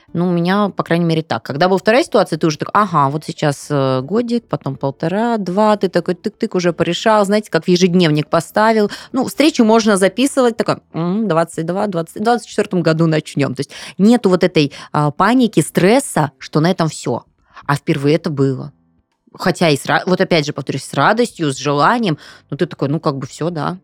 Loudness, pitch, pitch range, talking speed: -16 LUFS, 170 Hz, 150-205 Hz, 190 wpm